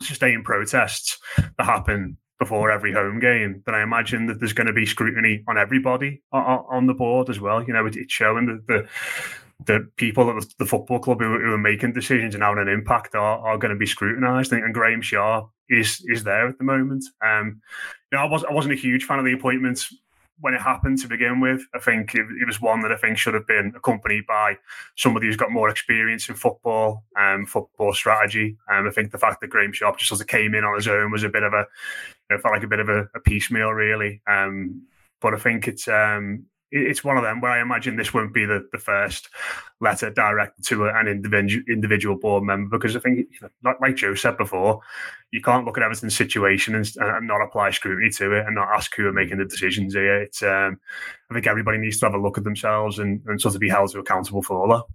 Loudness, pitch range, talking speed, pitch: -21 LUFS, 105-125 Hz, 235 wpm, 110 Hz